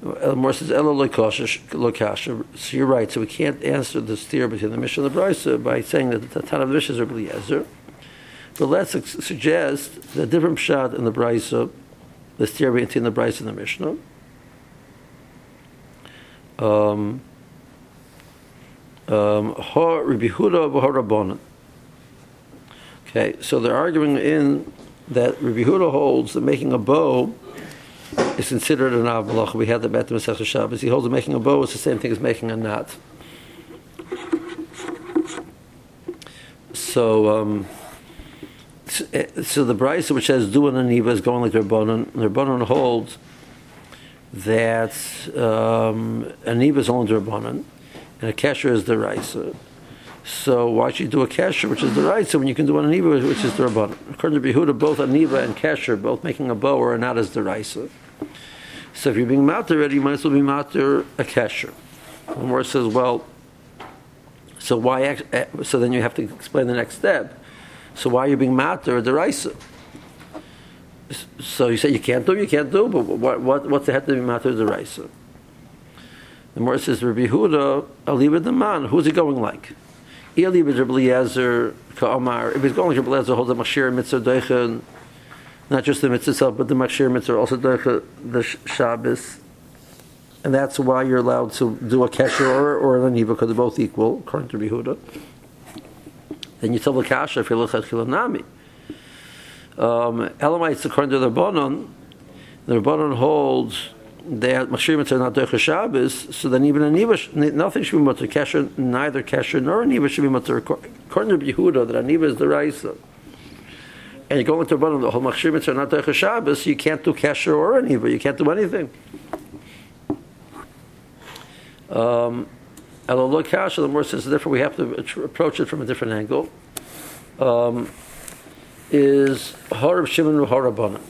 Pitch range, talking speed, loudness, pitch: 115-145 Hz, 160 wpm, -20 LUFS, 130 Hz